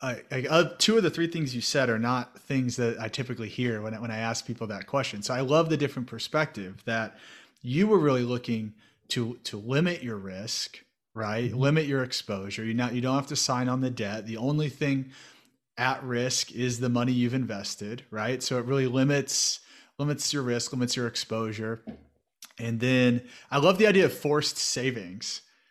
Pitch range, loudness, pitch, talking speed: 115-140 Hz, -28 LUFS, 125 Hz, 195 wpm